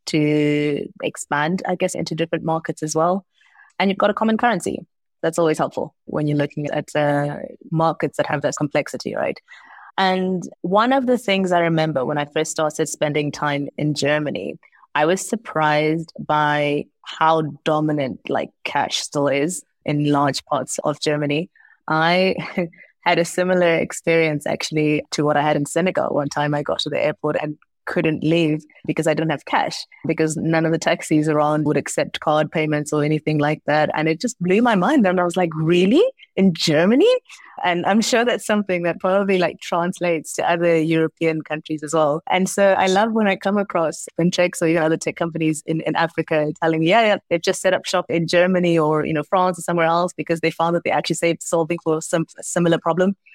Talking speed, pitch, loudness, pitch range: 200 wpm, 160 Hz, -20 LUFS, 150-180 Hz